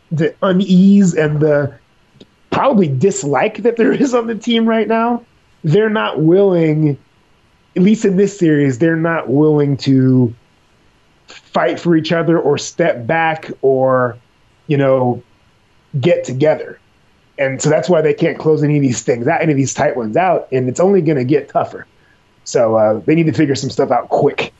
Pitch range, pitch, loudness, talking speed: 135-180 Hz, 155 Hz, -14 LUFS, 180 wpm